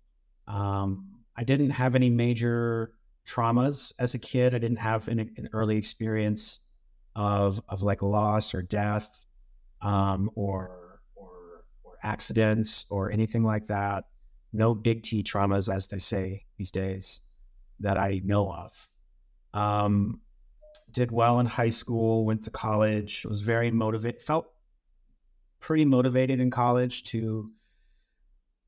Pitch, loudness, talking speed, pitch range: 105 Hz, -28 LUFS, 130 wpm, 95-115 Hz